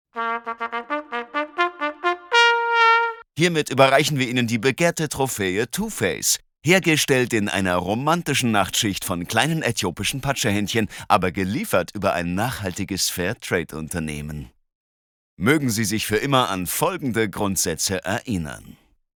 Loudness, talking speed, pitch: -21 LUFS, 100 wpm, 120 Hz